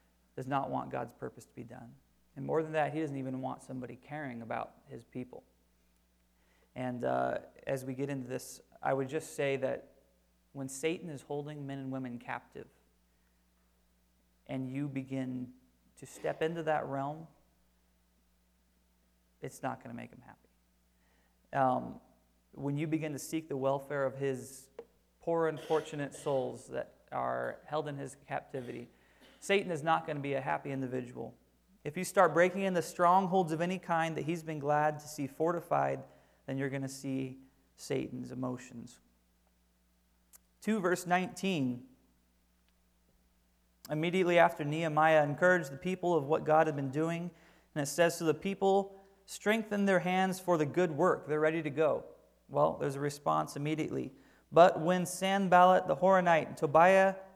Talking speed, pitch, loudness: 160 wpm, 140 Hz, -33 LUFS